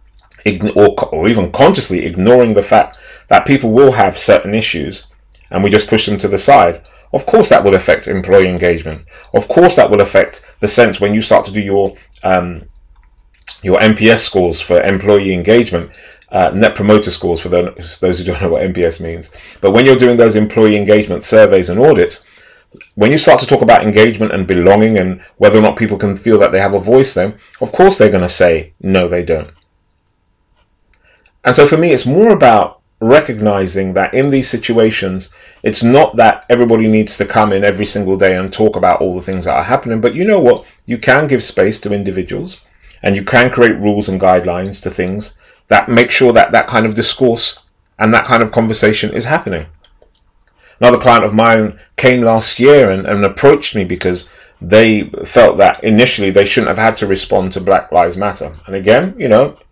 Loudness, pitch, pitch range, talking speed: -10 LUFS, 100 Hz, 90-115 Hz, 200 wpm